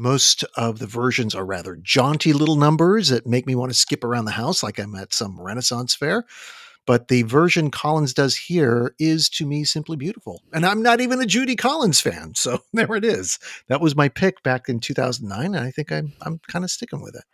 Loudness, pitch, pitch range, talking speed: -20 LUFS, 145 Hz, 120-175 Hz, 220 wpm